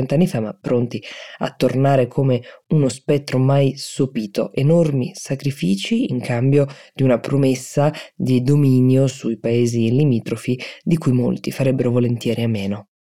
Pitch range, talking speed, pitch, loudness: 120-145 Hz, 135 wpm, 130 Hz, -19 LUFS